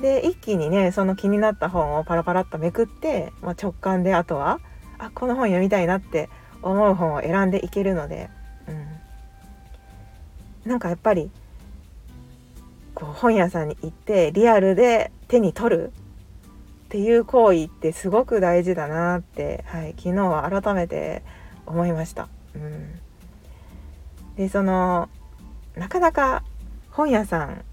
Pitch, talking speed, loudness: 175 Hz, 275 characters per minute, -22 LUFS